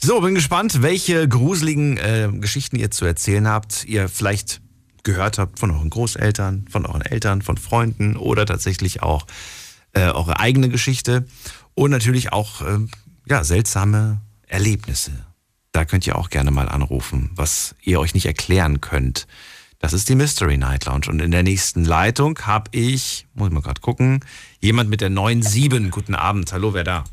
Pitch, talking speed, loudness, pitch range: 105 Hz, 170 wpm, -19 LUFS, 90-120 Hz